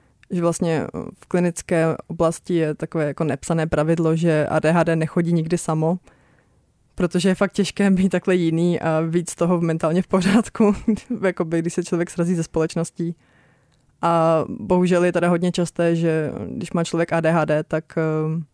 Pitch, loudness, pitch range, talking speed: 170 Hz, -21 LUFS, 160-180 Hz, 155 wpm